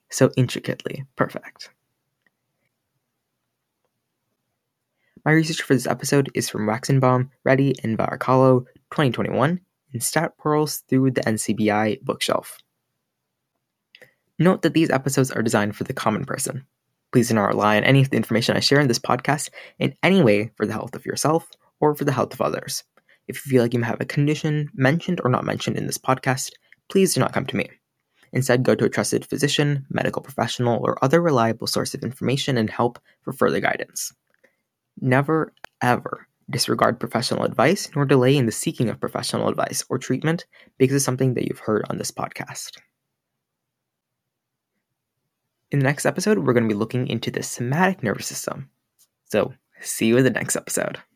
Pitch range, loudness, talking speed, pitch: 120-145 Hz, -22 LUFS, 170 wpm, 130 Hz